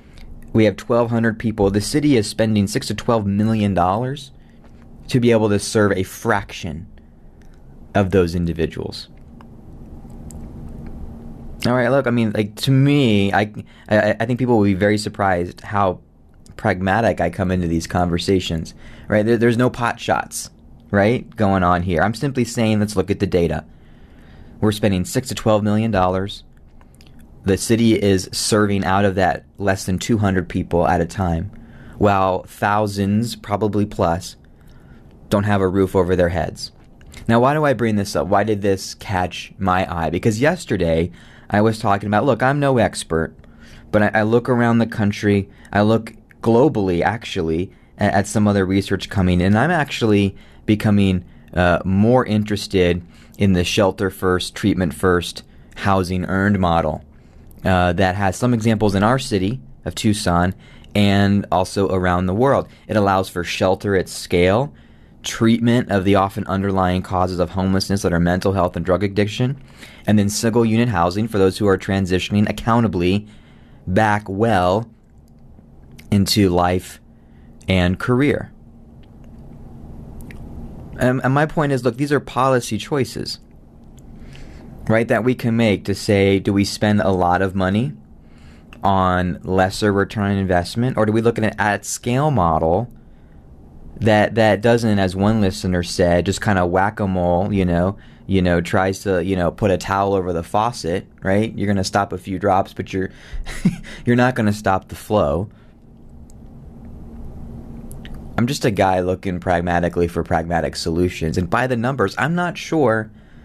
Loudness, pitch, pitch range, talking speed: -19 LUFS, 100 Hz, 90-110 Hz, 160 wpm